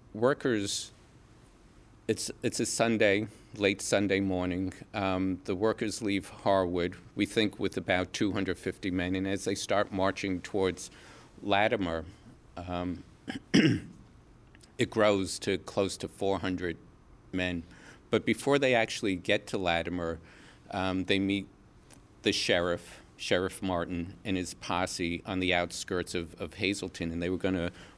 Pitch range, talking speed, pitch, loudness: 90-105 Hz, 135 wpm, 95 Hz, -31 LUFS